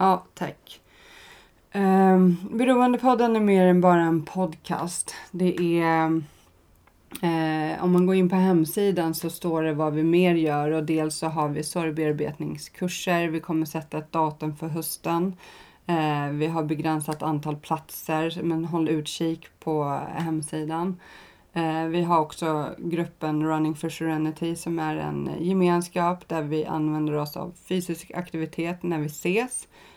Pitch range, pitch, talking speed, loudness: 155-175 Hz, 165 Hz, 135 wpm, -25 LUFS